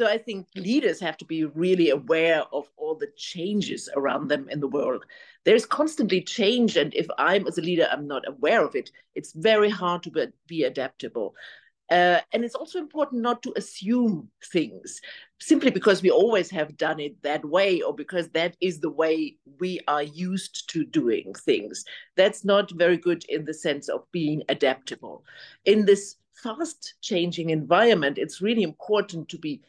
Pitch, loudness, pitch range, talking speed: 190 Hz, -25 LUFS, 165-240 Hz, 180 wpm